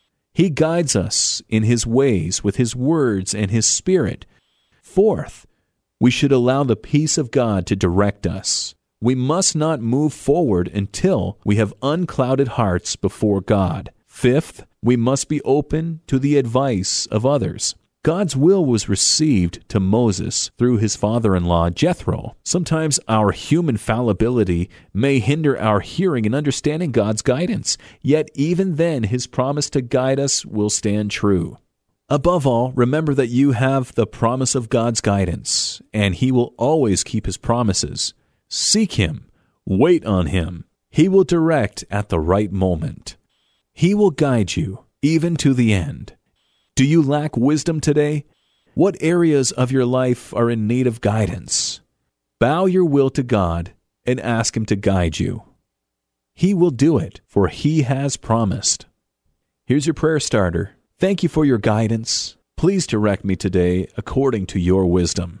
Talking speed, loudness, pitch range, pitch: 155 wpm, -18 LUFS, 100-145 Hz, 120 Hz